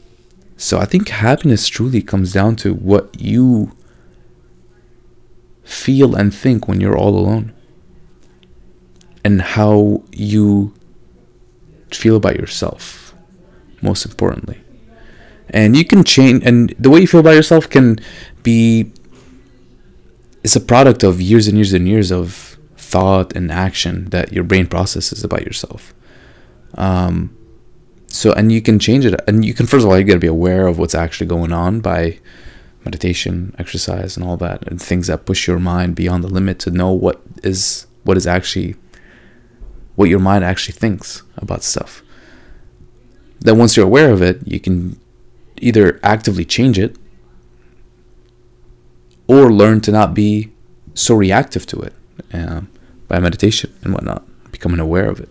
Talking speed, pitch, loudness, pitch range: 150 wpm, 95 Hz, -13 LUFS, 90-110 Hz